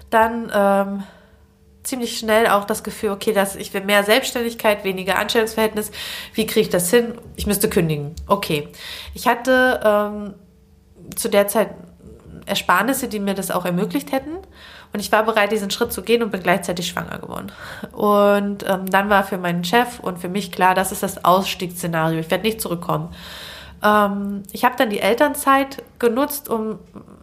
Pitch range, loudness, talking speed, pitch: 195-230 Hz, -19 LUFS, 170 wpm, 210 Hz